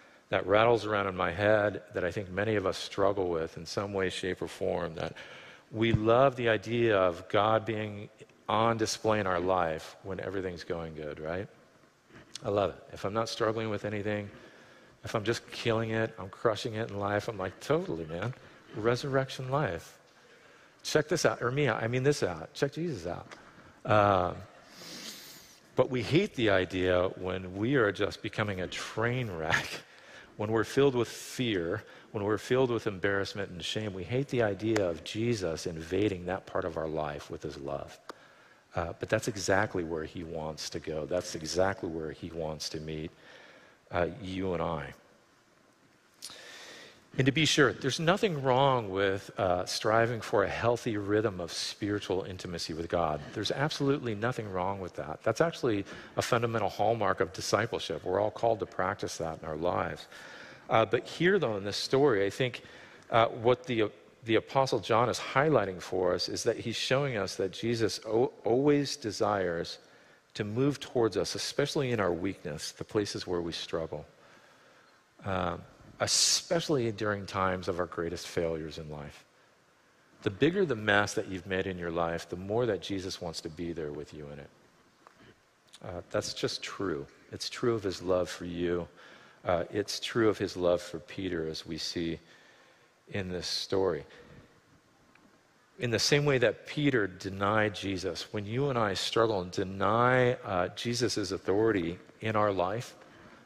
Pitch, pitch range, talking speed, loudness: 105 Hz, 90-115 Hz, 175 wpm, -31 LUFS